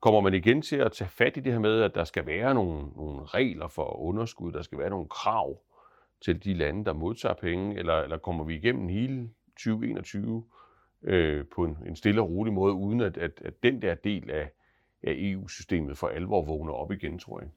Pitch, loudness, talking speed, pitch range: 95 Hz, -29 LUFS, 210 wpm, 80-110 Hz